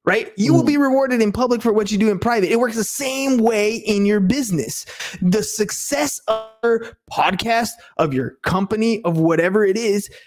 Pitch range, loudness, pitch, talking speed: 200-235 Hz, -19 LUFS, 220 Hz, 195 wpm